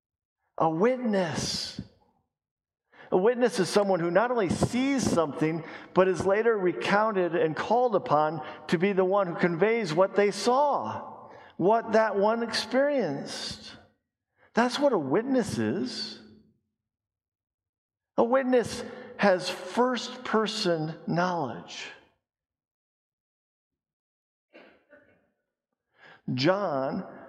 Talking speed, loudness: 95 wpm, -26 LUFS